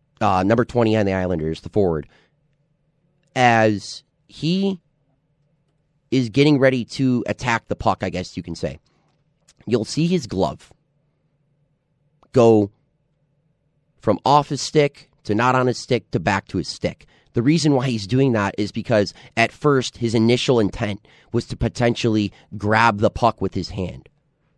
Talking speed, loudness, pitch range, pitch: 155 wpm, -20 LUFS, 110-150 Hz, 125 Hz